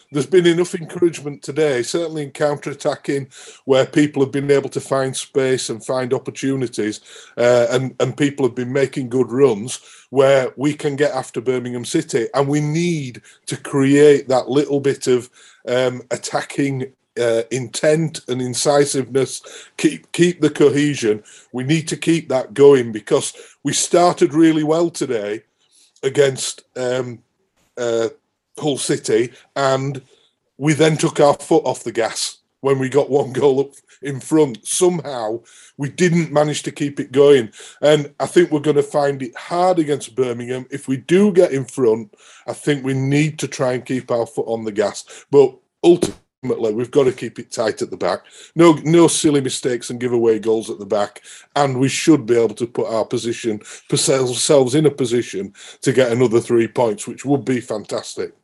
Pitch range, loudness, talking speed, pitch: 125-155 Hz, -18 LUFS, 175 wpm, 140 Hz